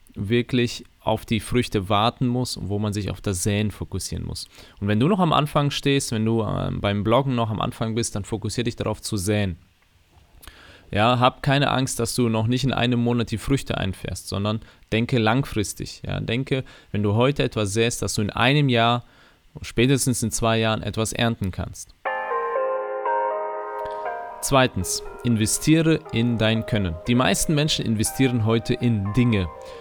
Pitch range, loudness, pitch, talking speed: 105-125 Hz, -23 LUFS, 115 Hz, 170 wpm